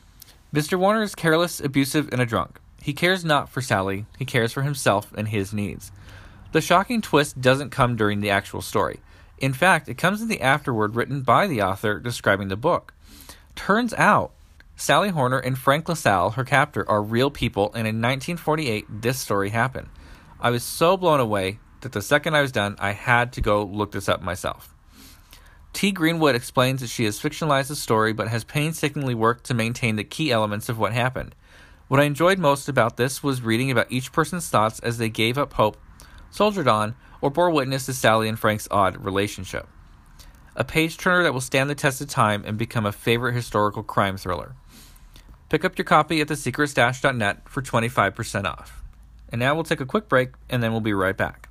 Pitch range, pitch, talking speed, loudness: 105-145 Hz, 120 Hz, 200 wpm, -22 LUFS